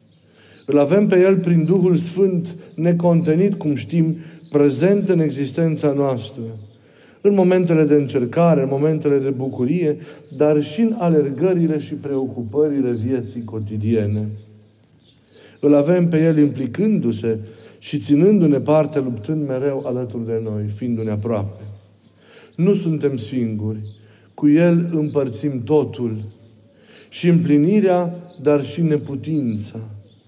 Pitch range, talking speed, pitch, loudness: 115-165 Hz, 115 wpm, 145 Hz, -18 LUFS